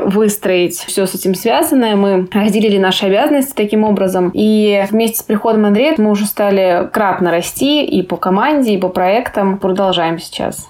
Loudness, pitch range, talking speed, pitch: -13 LUFS, 185-215 Hz, 165 wpm, 200 Hz